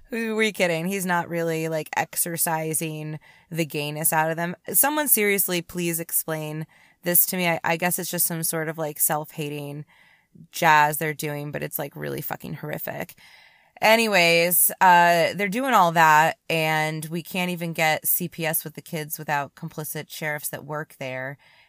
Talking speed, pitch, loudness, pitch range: 165 wpm, 165 Hz, -22 LUFS, 155-175 Hz